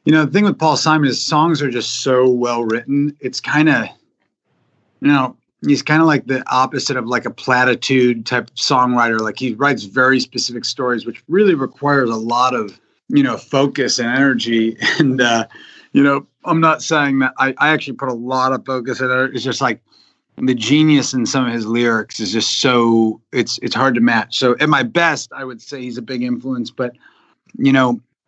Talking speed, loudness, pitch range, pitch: 210 wpm, -16 LUFS, 120-145 Hz, 130 Hz